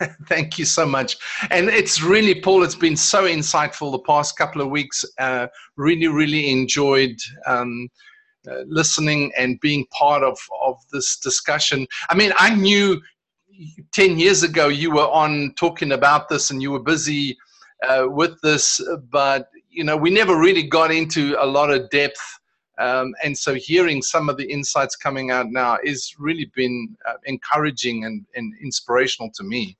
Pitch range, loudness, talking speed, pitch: 135-170 Hz, -18 LUFS, 170 wpm, 150 Hz